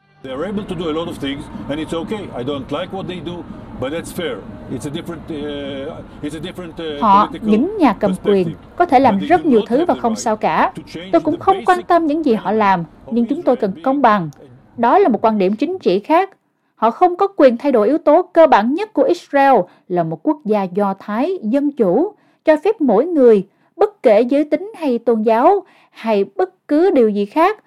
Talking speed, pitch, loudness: 165 wpm, 230 Hz, -16 LUFS